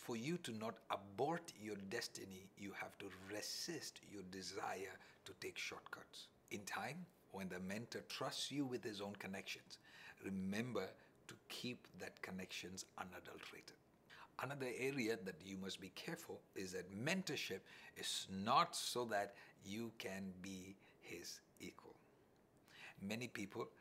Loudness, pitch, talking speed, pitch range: -48 LUFS, 100 Hz, 135 wpm, 95-120 Hz